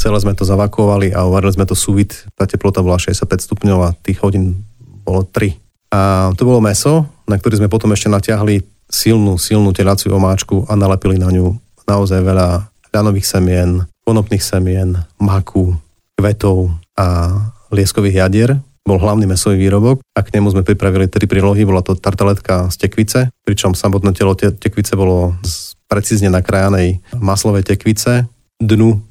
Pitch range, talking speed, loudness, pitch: 95-105 Hz, 155 wpm, -13 LUFS, 100 Hz